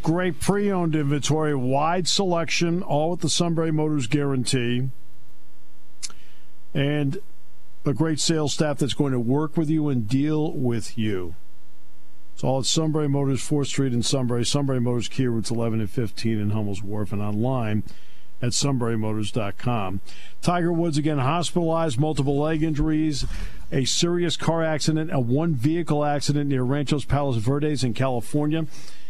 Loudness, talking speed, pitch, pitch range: -24 LUFS, 140 wpm, 140 Hz, 115-155 Hz